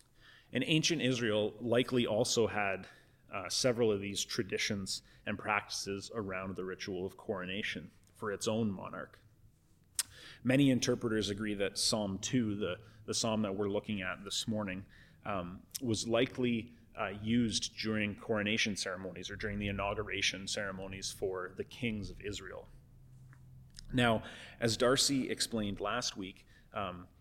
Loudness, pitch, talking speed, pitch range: -35 LUFS, 110 Hz, 135 wpm, 100-120 Hz